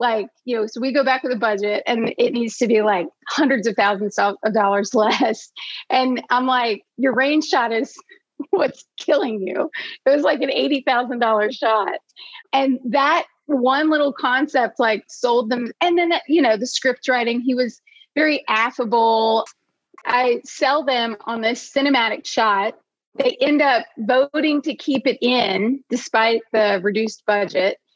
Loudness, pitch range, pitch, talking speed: -19 LUFS, 225-280 Hz, 250 Hz, 165 wpm